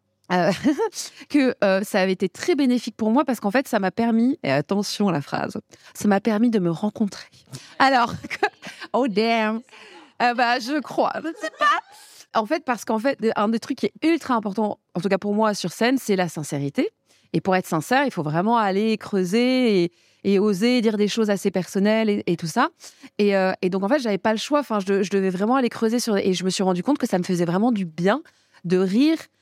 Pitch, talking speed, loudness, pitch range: 215 Hz, 235 wpm, -22 LUFS, 195-250 Hz